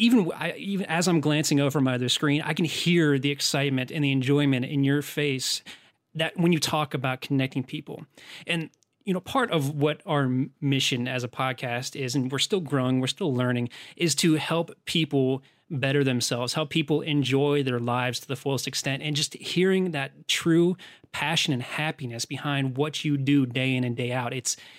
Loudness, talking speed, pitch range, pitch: -25 LUFS, 195 wpm, 130-160 Hz, 145 Hz